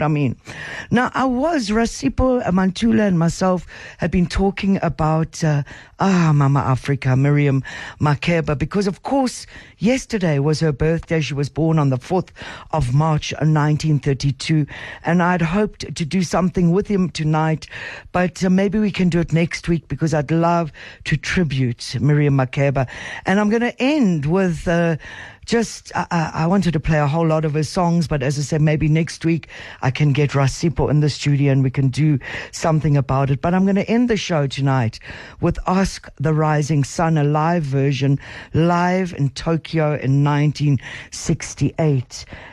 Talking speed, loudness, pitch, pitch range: 170 wpm, -19 LUFS, 155 Hz, 140-180 Hz